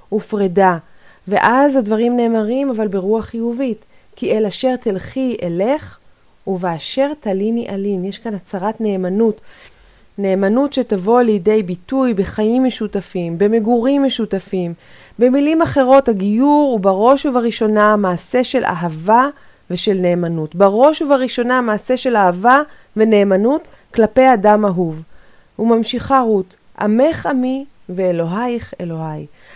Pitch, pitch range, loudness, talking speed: 220 Hz, 195-255 Hz, -16 LUFS, 110 wpm